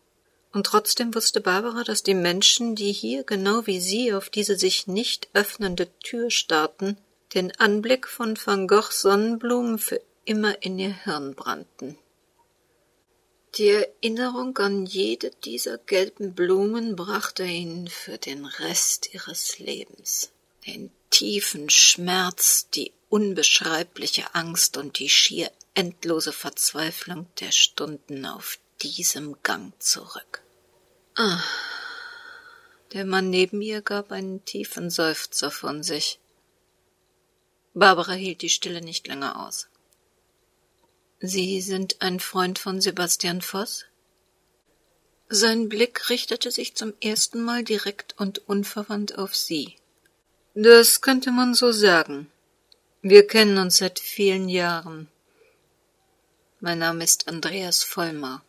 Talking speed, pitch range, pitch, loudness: 120 wpm, 180-225 Hz, 195 Hz, -22 LUFS